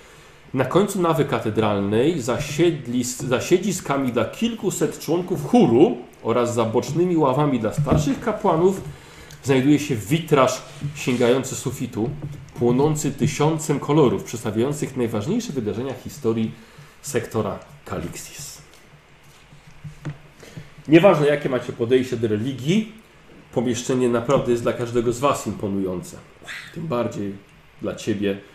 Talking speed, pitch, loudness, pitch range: 105 wpm, 140 Hz, -21 LUFS, 120-155 Hz